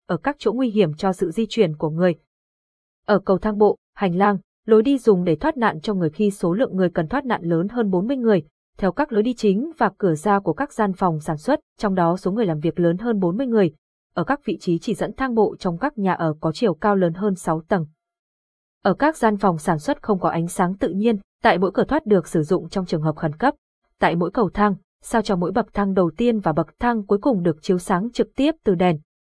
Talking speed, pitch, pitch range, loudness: 260 wpm, 200 Hz, 175-225 Hz, -21 LUFS